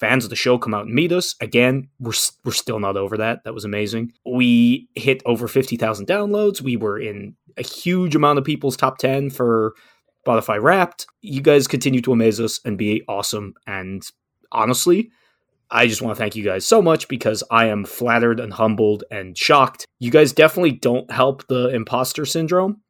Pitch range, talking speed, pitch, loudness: 110-140 Hz, 195 wpm, 125 Hz, -19 LUFS